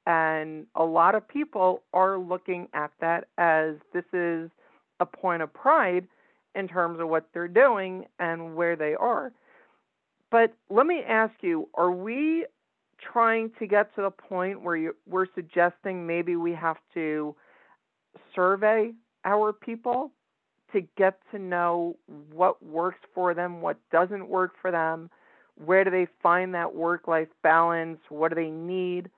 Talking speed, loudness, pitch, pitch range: 155 wpm, -26 LUFS, 180 Hz, 165-195 Hz